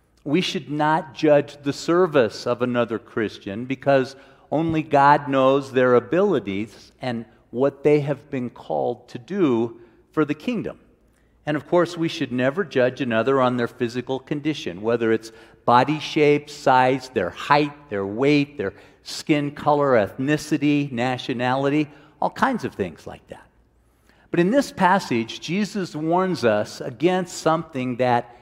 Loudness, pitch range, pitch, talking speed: -22 LUFS, 125-150 Hz, 140 Hz, 145 wpm